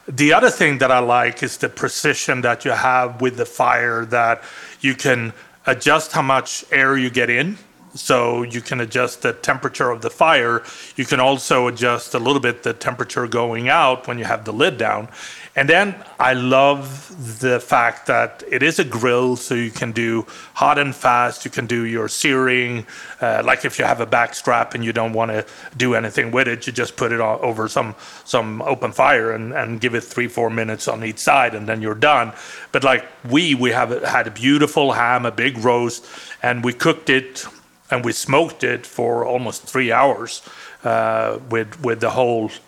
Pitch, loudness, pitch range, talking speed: 125 Hz, -18 LUFS, 115-135 Hz, 200 wpm